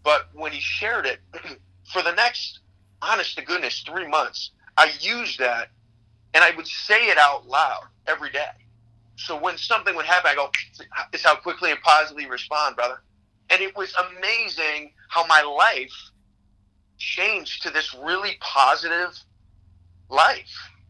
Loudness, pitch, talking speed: -21 LUFS, 120 Hz, 150 wpm